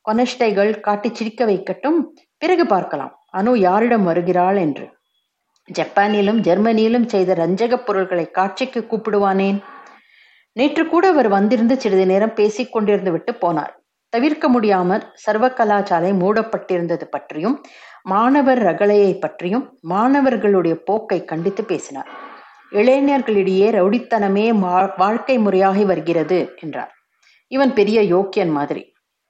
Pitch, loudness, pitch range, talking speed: 205 Hz, -17 LUFS, 185-240 Hz, 100 wpm